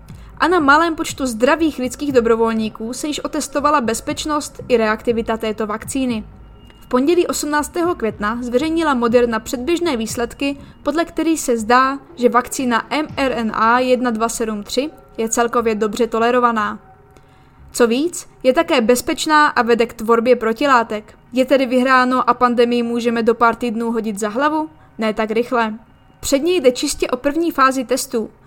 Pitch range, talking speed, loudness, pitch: 230-290 Hz, 140 wpm, -17 LUFS, 250 Hz